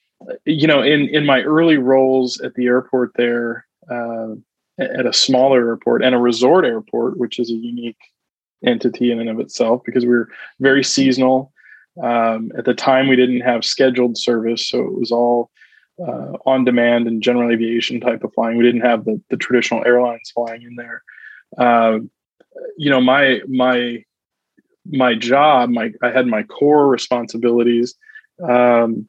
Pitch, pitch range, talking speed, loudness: 125 Hz, 120-130 Hz, 165 wpm, -16 LUFS